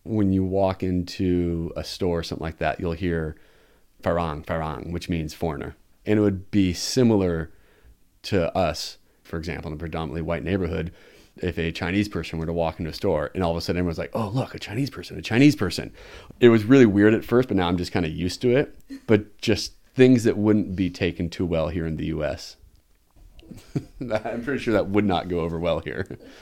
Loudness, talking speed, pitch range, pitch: -24 LUFS, 215 wpm, 85-105 Hz, 90 Hz